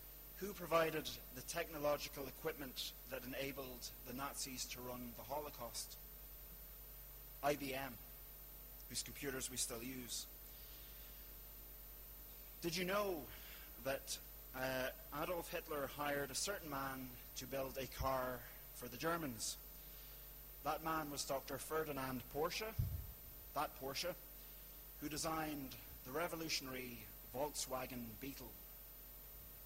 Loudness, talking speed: -46 LUFS, 105 wpm